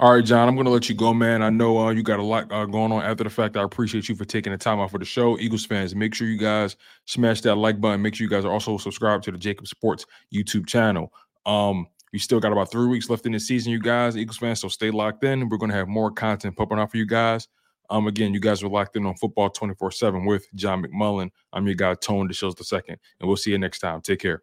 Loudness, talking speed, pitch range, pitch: -23 LUFS, 285 wpm, 100-115 Hz, 110 Hz